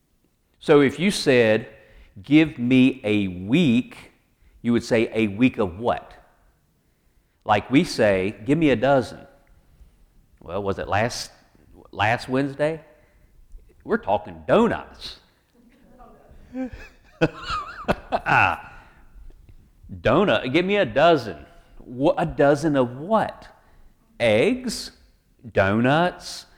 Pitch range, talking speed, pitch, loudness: 100-160 Hz, 95 wpm, 130 Hz, -21 LUFS